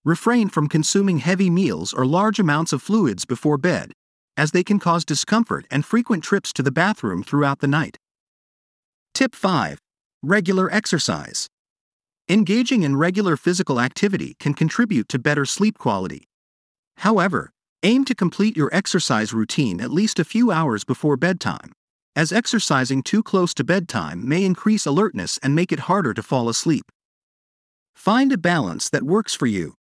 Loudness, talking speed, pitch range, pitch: -20 LUFS, 155 wpm, 145-205 Hz, 175 Hz